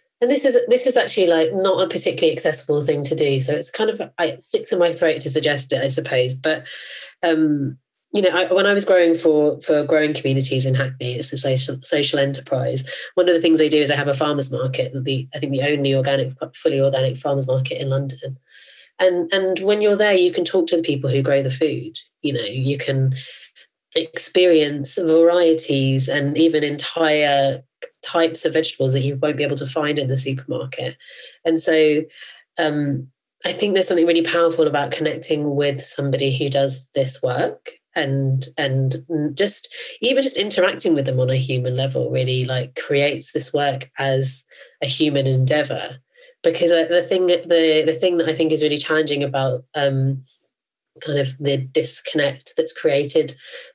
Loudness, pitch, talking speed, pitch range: -19 LUFS, 150 Hz, 185 wpm, 135-170 Hz